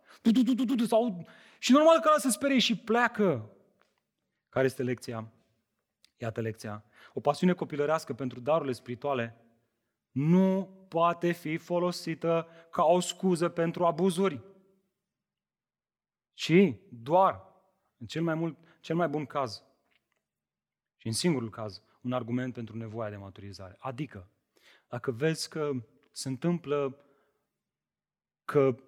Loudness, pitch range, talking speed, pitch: -29 LUFS, 120-180 Hz, 115 wpm, 150 Hz